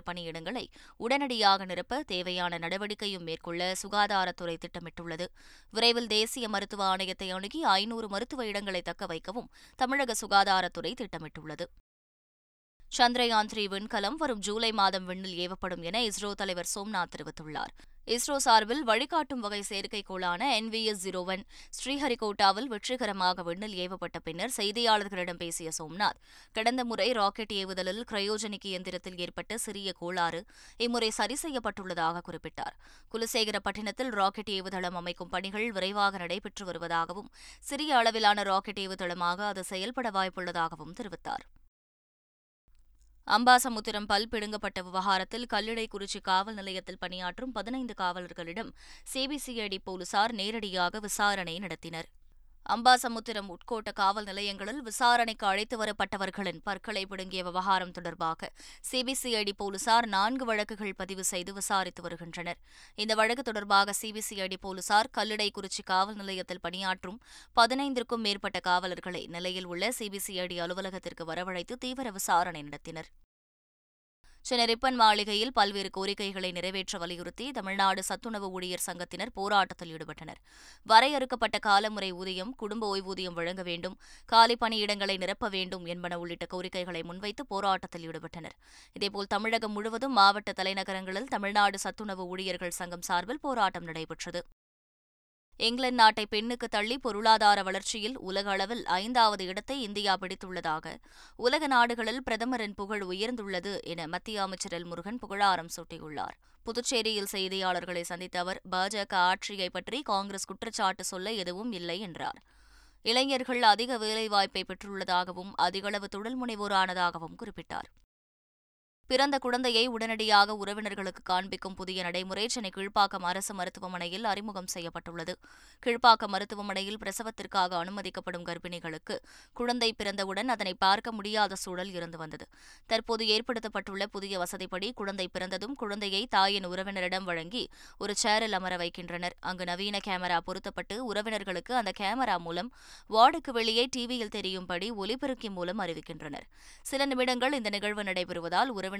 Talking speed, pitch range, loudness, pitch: 115 wpm, 180-220 Hz, -30 LUFS, 195 Hz